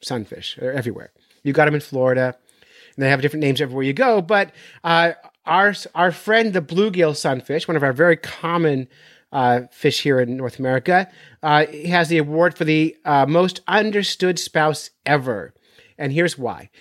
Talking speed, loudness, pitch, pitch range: 180 wpm, -19 LUFS, 155 Hz, 140-175 Hz